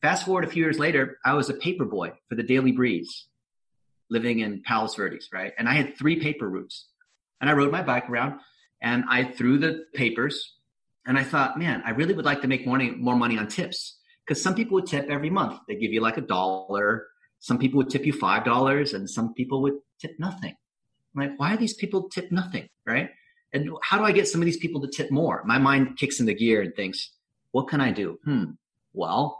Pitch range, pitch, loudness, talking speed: 120-170 Hz, 140 Hz, -25 LUFS, 225 wpm